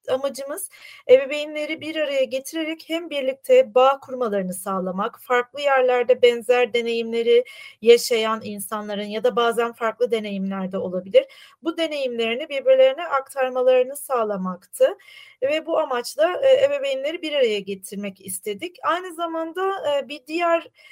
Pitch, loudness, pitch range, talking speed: 265 Hz, -22 LUFS, 230-305 Hz, 110 wpm